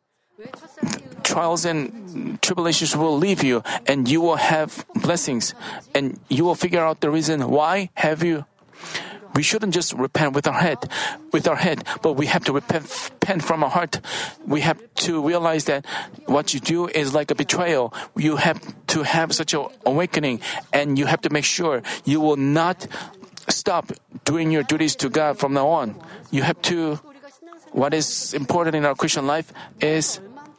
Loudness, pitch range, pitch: -21 LUFS, 145-175 Hz, 160 Hz